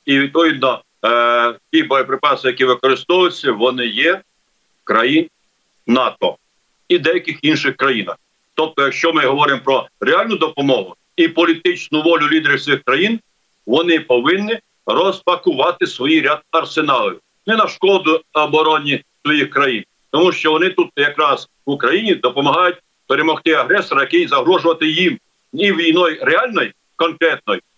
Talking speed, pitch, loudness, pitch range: 125 wpm, 165 Hz, -15 LUFS, 150-195 Hz